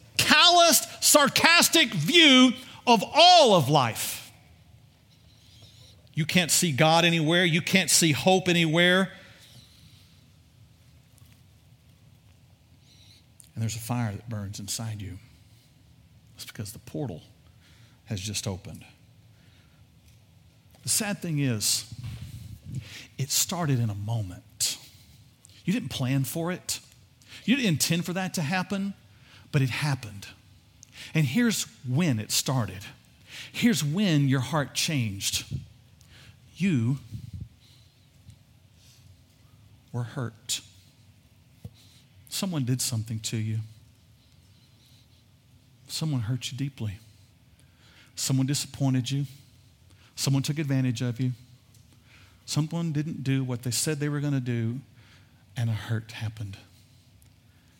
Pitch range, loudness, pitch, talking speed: 110-140 Hz, -24 LUFS, 120 Hz, 105 wpm